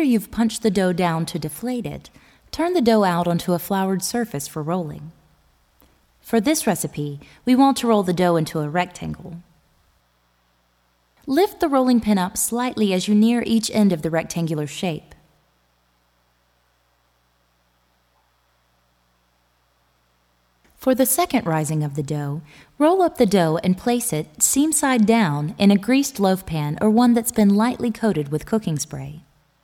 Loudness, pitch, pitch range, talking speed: -20 LUFS, 175 Hz, 140-225 Hz, 155 wpm